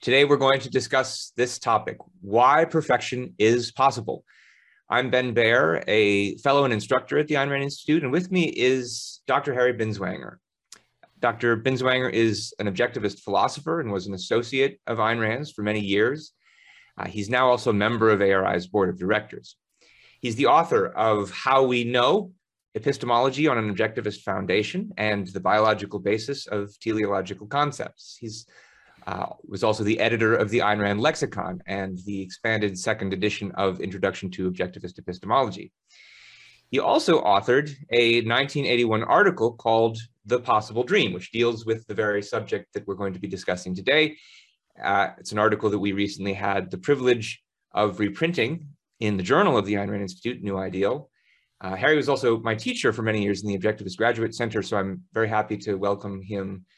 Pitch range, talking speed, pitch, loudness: 100-130 Hz, 170 wpm, 115 Hz, -24 LUFS